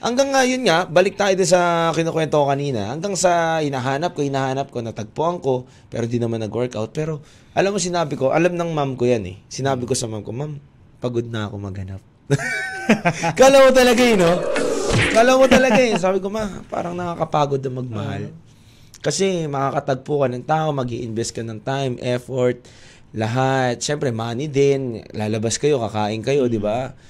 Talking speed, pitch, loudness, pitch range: 180 wpm, 135 Hz, -19 LUFS, 120-170 Hz